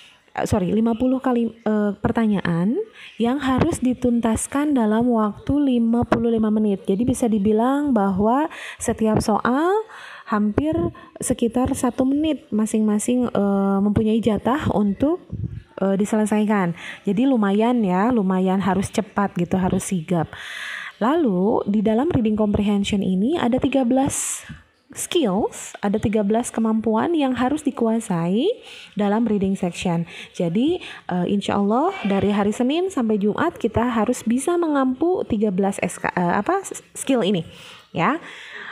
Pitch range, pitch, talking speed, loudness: 205-255 Hz, 225 Hz, 120 wpm, -21 LUFS